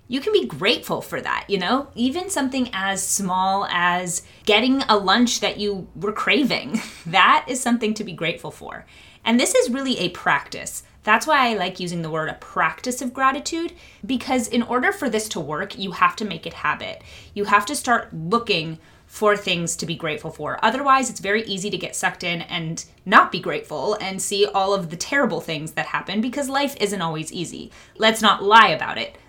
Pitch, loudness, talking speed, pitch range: 205 Hz, -21 LUFS, 205 wpm, 180-250 Hz